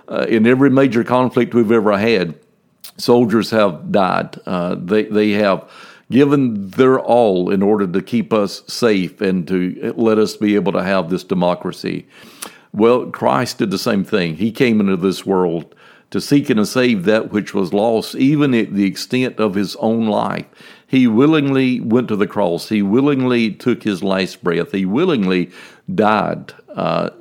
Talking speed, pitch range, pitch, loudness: 170 wpm, 95-125 Hz, 110 Hz, -16 LUFS